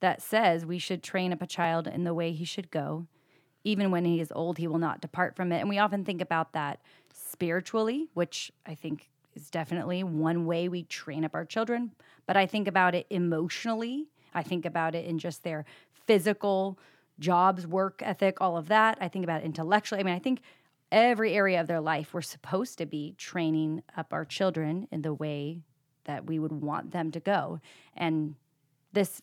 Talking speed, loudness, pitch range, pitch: 200 wpm, -30 LUFS, 160-195 Hz, 170 Hz